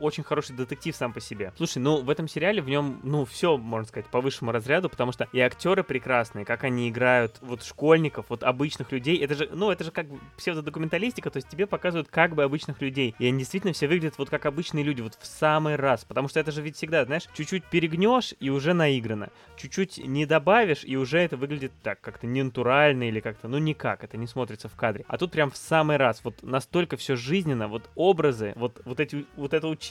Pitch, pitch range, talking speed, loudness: 145 Hz, 125-160 Hz, 225 wpm, -26 LUFS